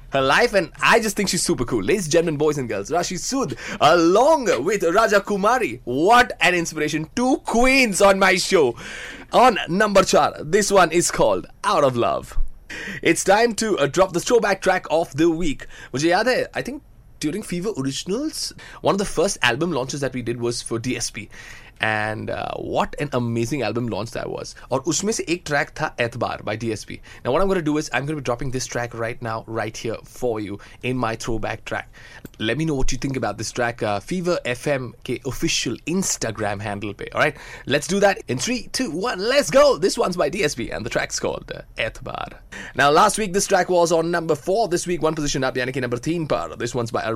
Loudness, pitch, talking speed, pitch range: -21 LUFS, 155 Hz, 210 wpm, 120-190 Hz